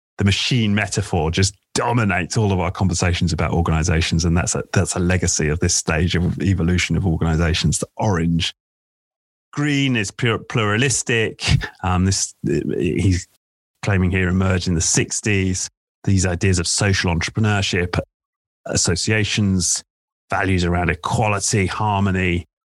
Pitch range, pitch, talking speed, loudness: 85-100 Hz, 95 Hz, 125 wpm, -19 LUFS